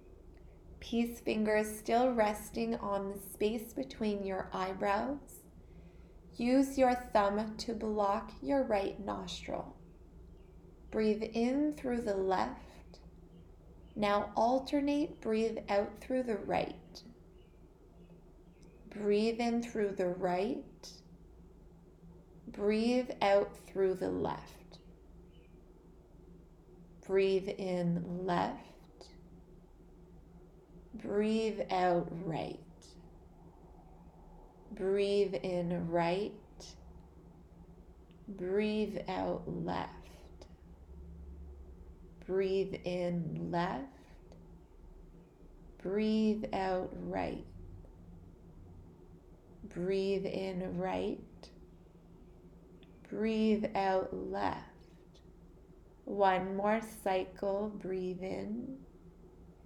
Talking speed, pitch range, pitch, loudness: 70 wpm, 175-215 Hz, 195 Hz, -35 LUFS